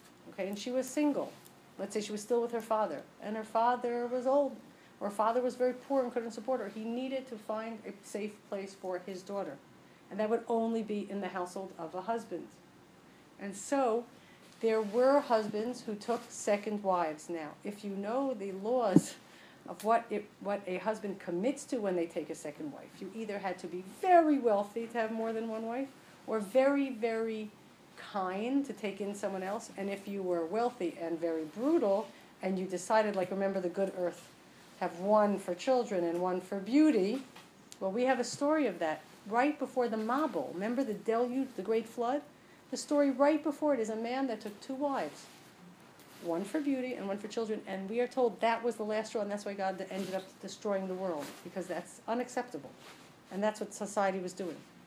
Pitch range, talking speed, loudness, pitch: 195-245 Hz, 205 wpm, -34 LUFS, 215 Hz